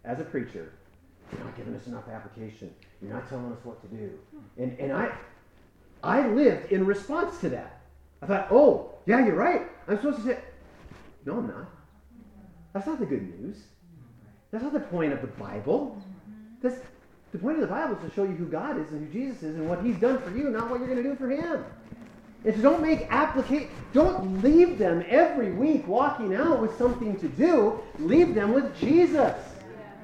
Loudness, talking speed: -26 LUFS, 200 wpm